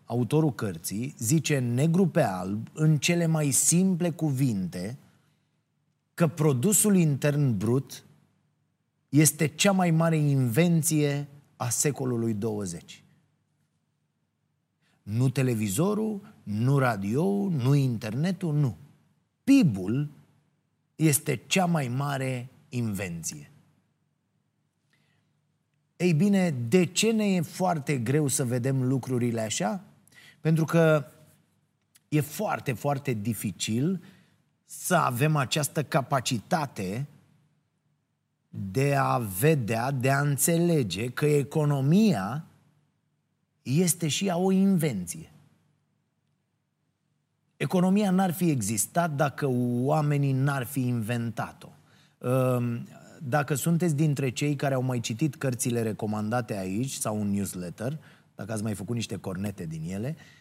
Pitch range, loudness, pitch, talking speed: 125-160 Hz, -26 LUFS, 145 Hz, 100 wpm